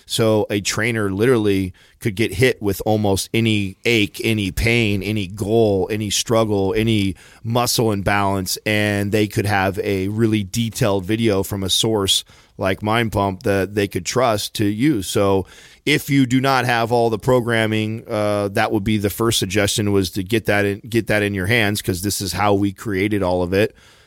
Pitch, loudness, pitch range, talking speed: 105 Hz, -19 LUFS, 100-115 Hz, 185 wpm